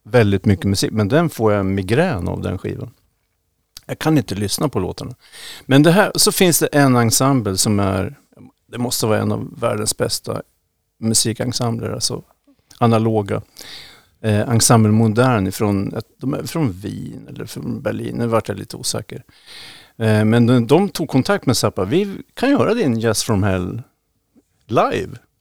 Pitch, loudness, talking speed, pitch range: 115 Hz, -17 LUFS, 165 wpm, 105-135 Hz